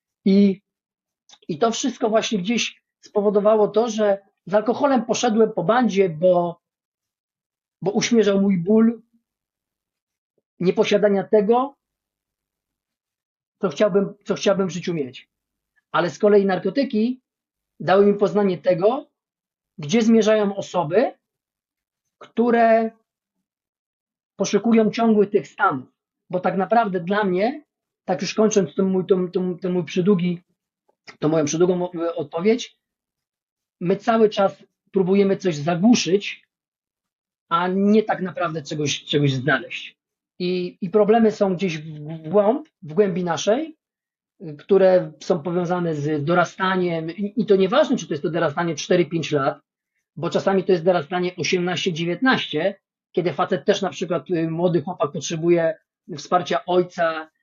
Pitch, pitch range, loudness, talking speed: 195 Hz, 175-215 Hz, -21 LUFS, 120 wpm